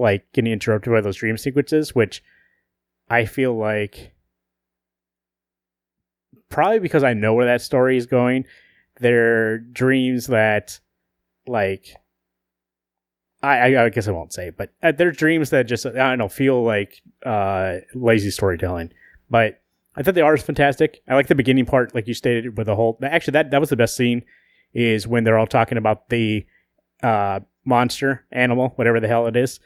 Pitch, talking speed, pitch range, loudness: 115 Hz, 170 wpm, 95-130 Hz, -19 LUFS